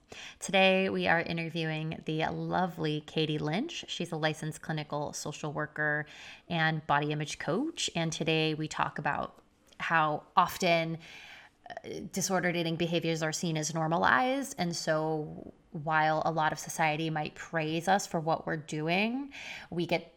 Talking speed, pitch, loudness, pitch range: 145 wpm, 165 Hz, -31 LUFS, 155-175 Hz